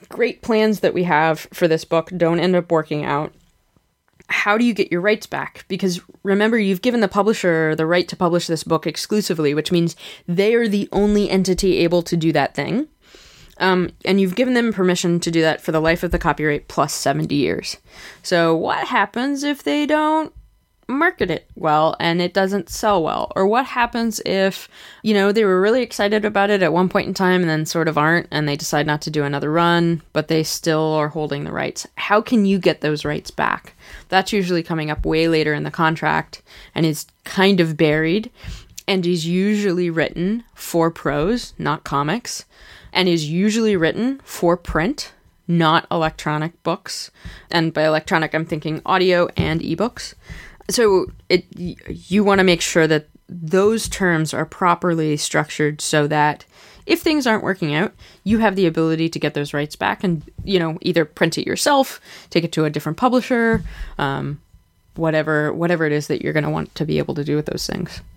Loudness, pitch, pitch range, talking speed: -19 LUFS, 175 Hz, 155-200 Hz, 195 wpm